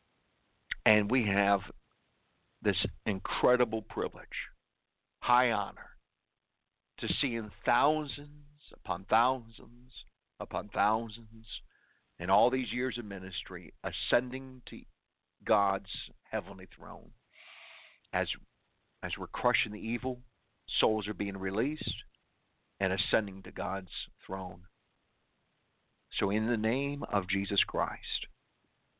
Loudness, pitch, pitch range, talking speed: -32 LUFS, 110 Hz, 100-125 Hz, 100 wpm